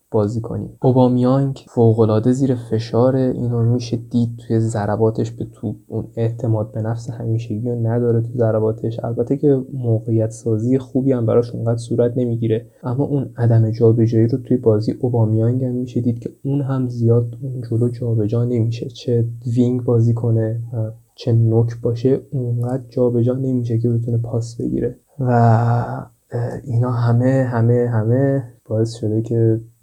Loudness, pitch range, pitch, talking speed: -19 LUFS, 115-125 Hz, 120 Hz, 150 wpm